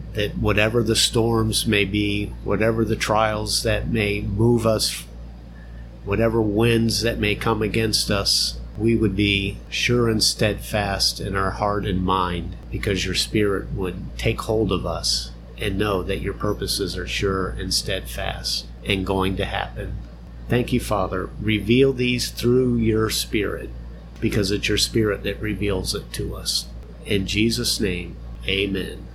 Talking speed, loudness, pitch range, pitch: 150 wpm, -22 LUFS, 95-110 Hz, 100 Hz